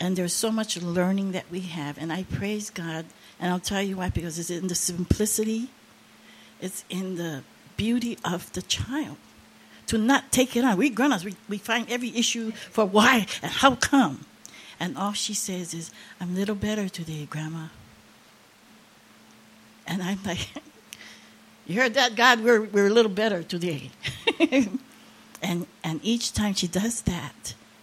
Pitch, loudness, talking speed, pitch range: 205 Hz, -25 LUFS, 165 wpm, 180-235 Hz